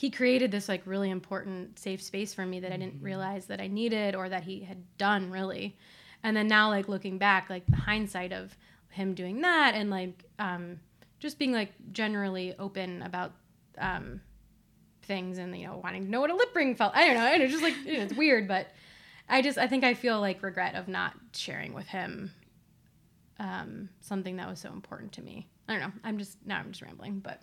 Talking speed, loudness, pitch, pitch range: 220 wpm, -30 LUFS, 195 Hz, 185-220 Hz